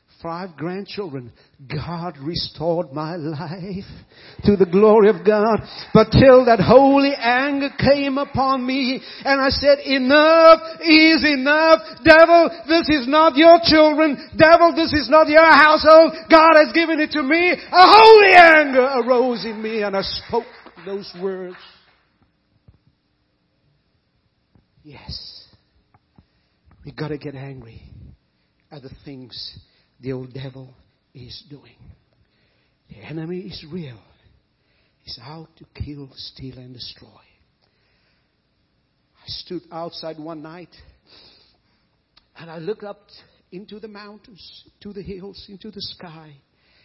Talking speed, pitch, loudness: 125 wpm, 205 Hz, -13 LUFS